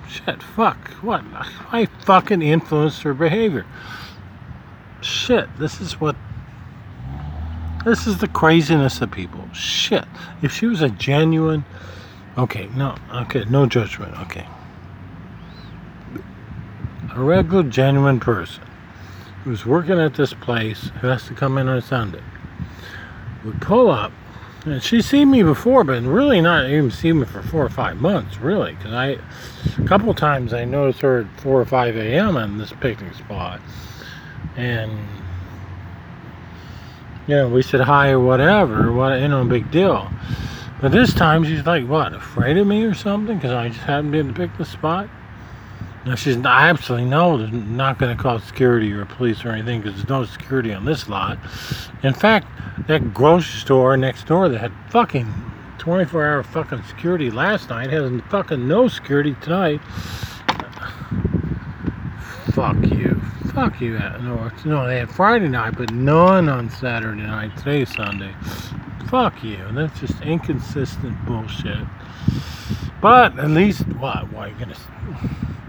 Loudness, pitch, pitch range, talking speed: -19 LUFS, 125 Hz, 110-155 Hz, 150 wpm